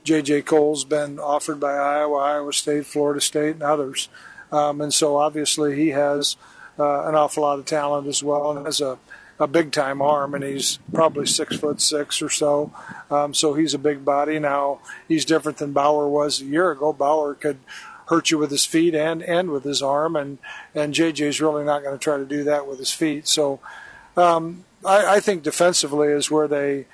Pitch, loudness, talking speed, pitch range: 150 Hz, -21 LUFS, 205 wpm, 145-155 Hz